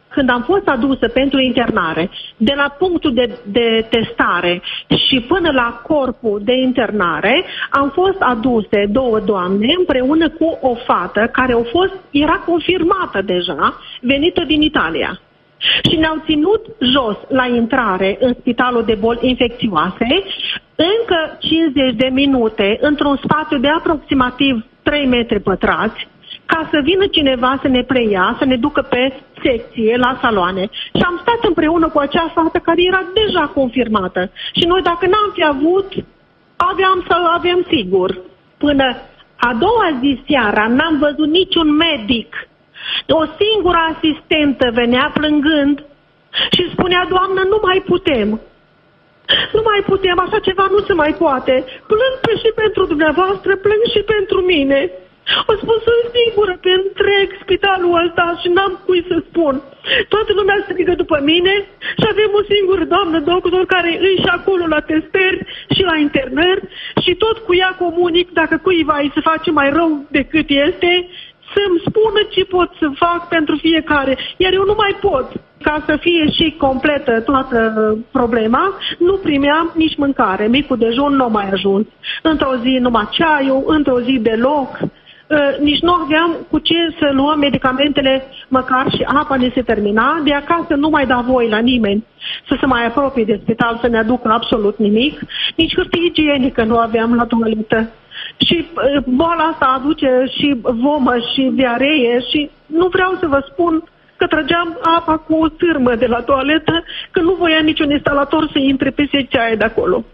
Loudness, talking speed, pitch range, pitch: -14 LUFS, 160 wpm, 250-350 Hz, 295 Hz